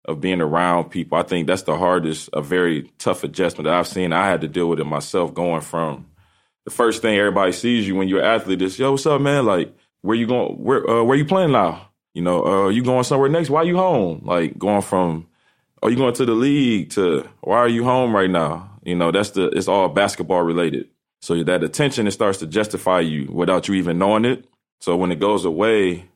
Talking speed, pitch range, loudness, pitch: 240 wpm, 85-120 Hz, -19 LUFS, 95 Hz